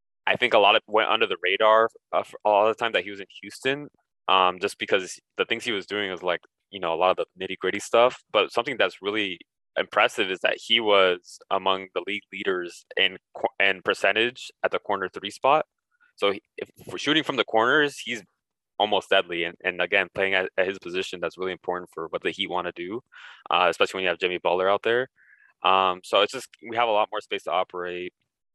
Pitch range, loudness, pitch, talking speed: 90-135 Hz, -24 LUFS, 95 Hz, 225 wpm